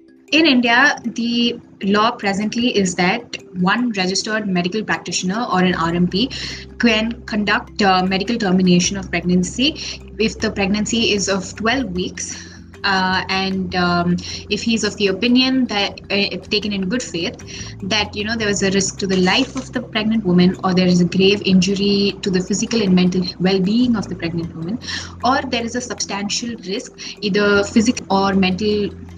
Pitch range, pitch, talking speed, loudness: 185-230 Hz, 200 Hz, 175 wpm, -18 LUFS